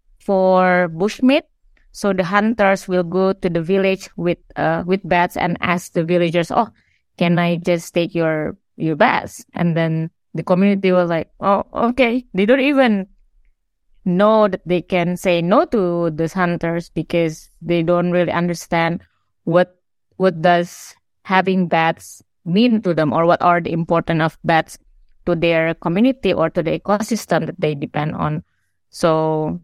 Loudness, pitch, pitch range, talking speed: -18 LUFS, 175 Hz, 165-195 Hz, 160 wpm